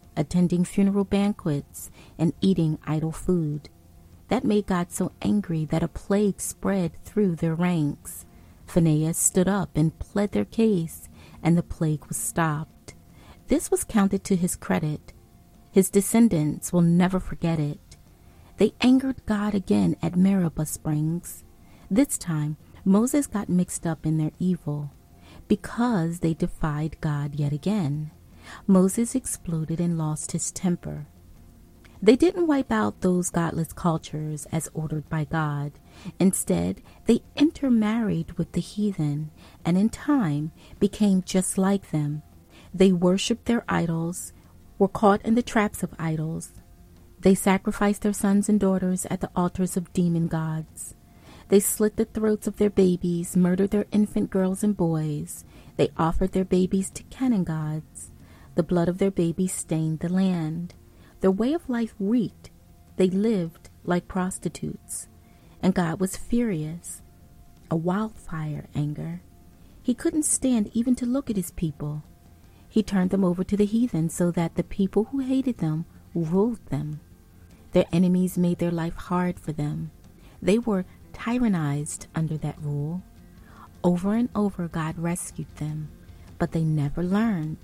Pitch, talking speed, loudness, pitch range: 175 Hz, 145 wpm, -25 LUFS, 150-200 Hz